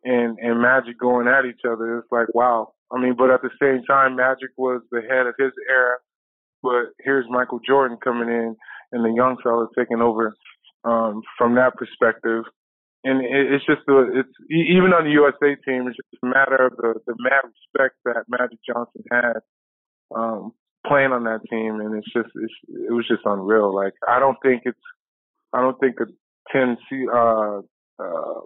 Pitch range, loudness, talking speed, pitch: 115-130 Hz, -20 LUFS, 190 wpm, 125 Hz